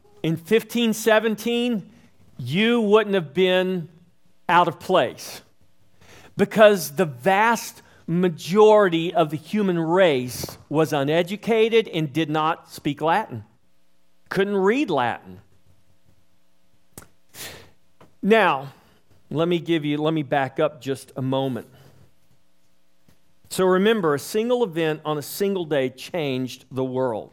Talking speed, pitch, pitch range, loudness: 110 wpm, 160 Hz, 130-195 Hz, -21 LUFS